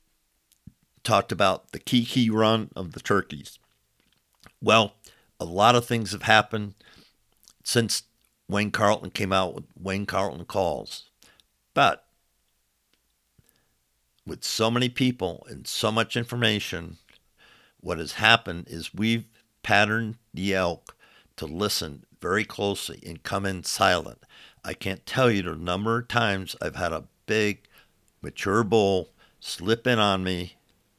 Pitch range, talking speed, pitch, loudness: 90-115 Hz, 130 wpm, 100 Hz, -25 LUFS